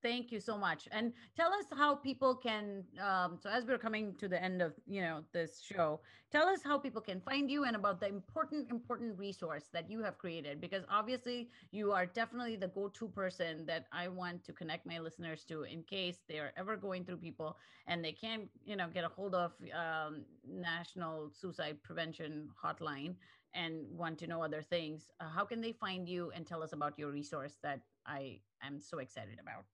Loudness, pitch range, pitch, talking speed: -40 LUFS, 160-215 Hz, 180 Hz, 205 wpm